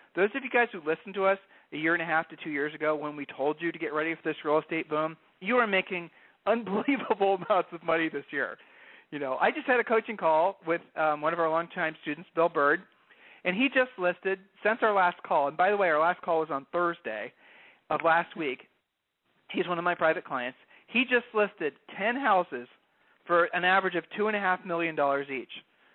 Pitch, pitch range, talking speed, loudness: 170 Hz, 160-195 Hz, 225 wpm, -28 LUFS